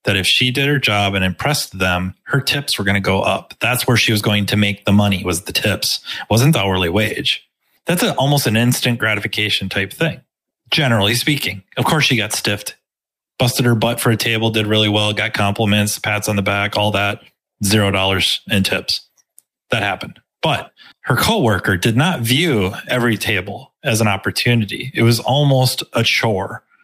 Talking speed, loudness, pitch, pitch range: 195 wpm, -16 LUFS, 110 Hz, 100-125 Hz